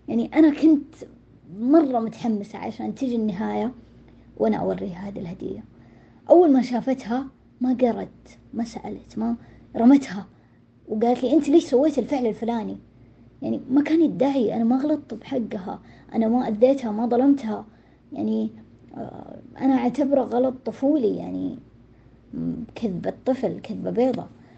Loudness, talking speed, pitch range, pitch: -23 LUFS, 120 wpm, 205-265 Hz, 235 Hz